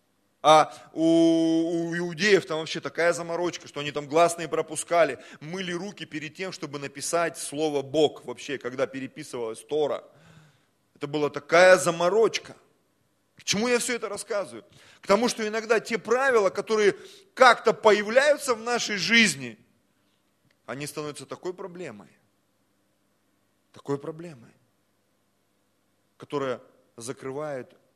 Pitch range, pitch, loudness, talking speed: 130-190 Hz, 160 Hz, -24 LUFS, 115 wpm